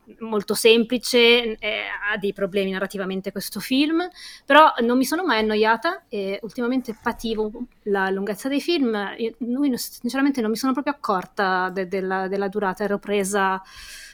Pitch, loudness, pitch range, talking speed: 220 Hz, -22 LUFS, 200-250 Hz, 155 wpm